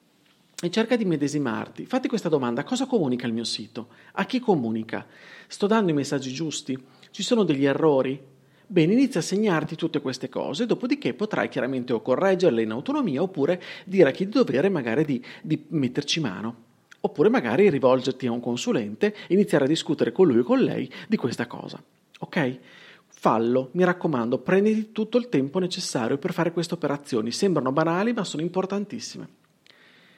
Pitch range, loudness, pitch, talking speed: 130-205 Hz, -24 LUFS, 170 Hz, 170 wpm